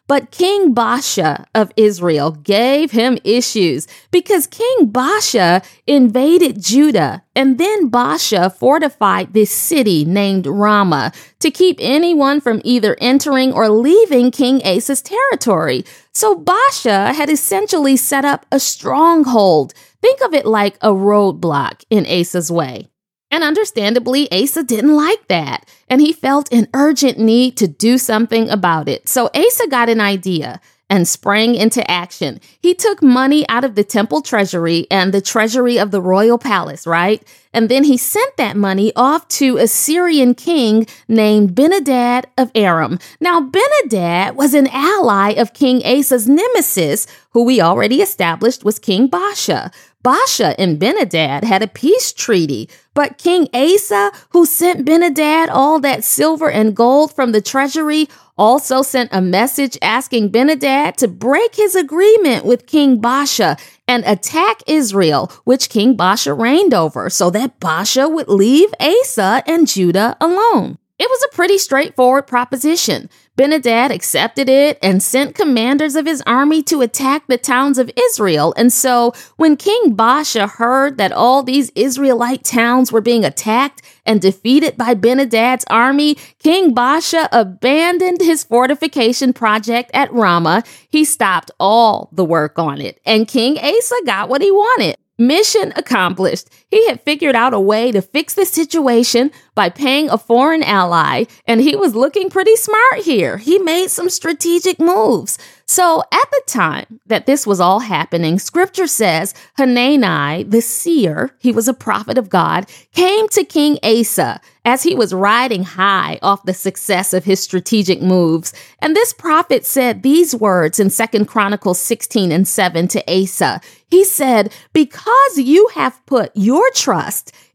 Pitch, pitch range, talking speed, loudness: 250 Hz, 210-305 Hz, 150 wpm, -13 LUFS